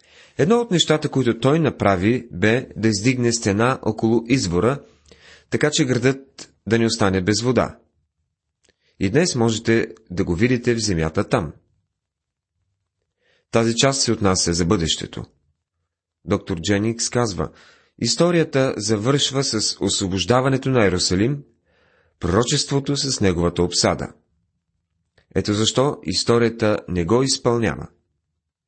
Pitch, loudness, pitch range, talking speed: 110 Hz, -20 LUFS, 90-125 Hz, 115 wpm